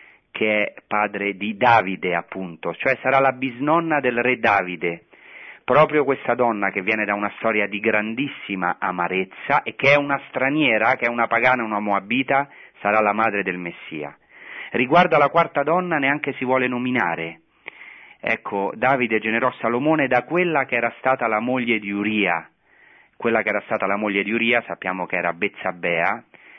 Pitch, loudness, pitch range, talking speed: 115 Hz, -20 LUFS, 100-130 Hz, 165 wpm